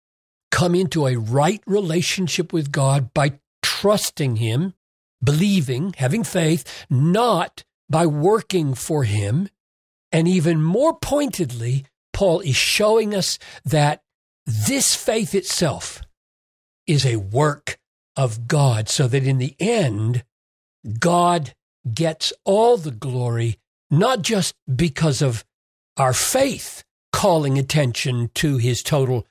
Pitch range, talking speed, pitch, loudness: 125-175 Hz, 115 wpm, 145 Hz, -20 LUFS